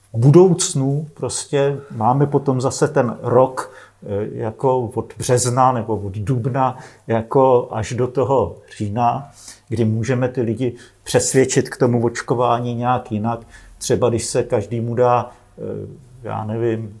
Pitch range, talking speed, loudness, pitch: 115-130 Hz, 125 wpm, -19 LUFS, 125 Hz